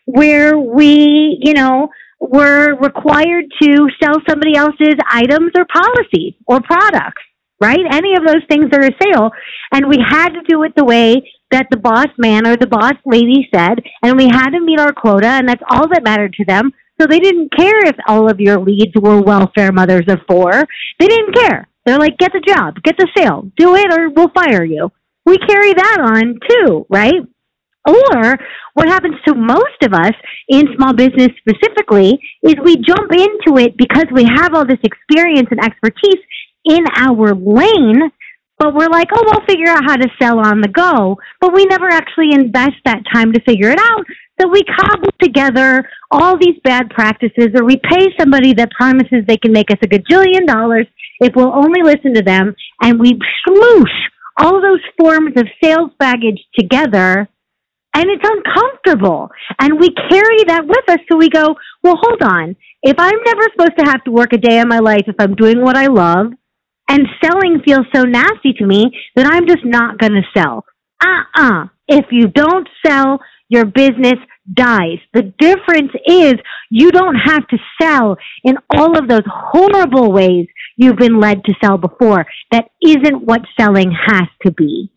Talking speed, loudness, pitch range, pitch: 185 wpm, -10 LUFS, 230-330 Hz, 275 Hz